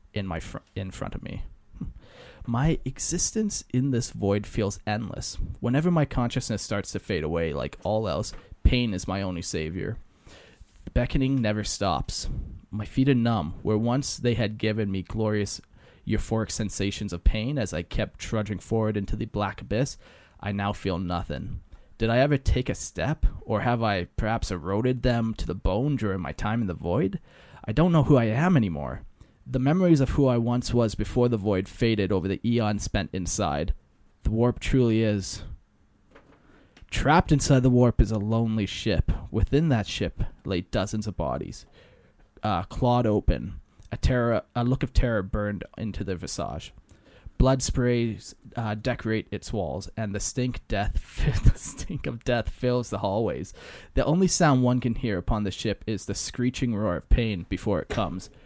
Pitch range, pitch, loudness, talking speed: 95-125 Hz, 110 Hz, -27 LUFS, 175 wpm